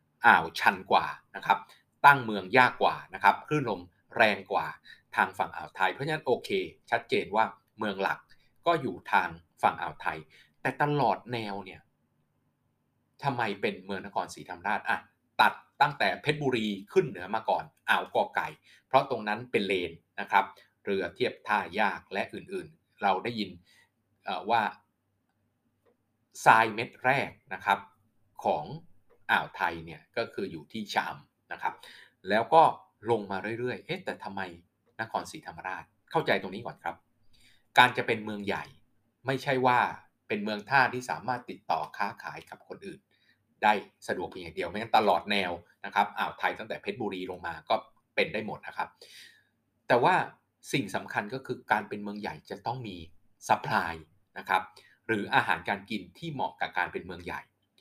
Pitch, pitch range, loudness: 105 Hz, 95-120 Hz, -29 LUFS